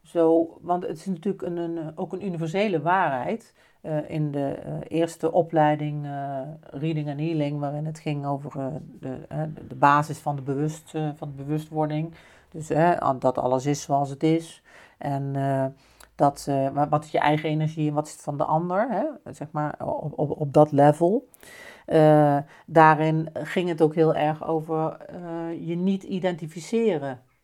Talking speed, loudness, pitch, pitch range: 175 wpm, -25 LUFS, 155 Hz, 145-165 Hz